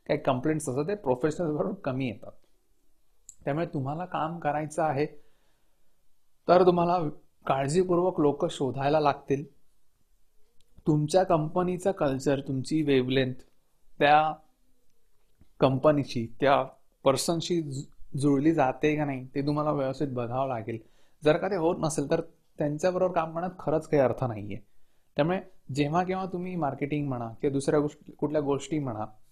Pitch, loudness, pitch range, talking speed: 150 Hz, -28 LUFS, 135-165 Hz, 125 wpm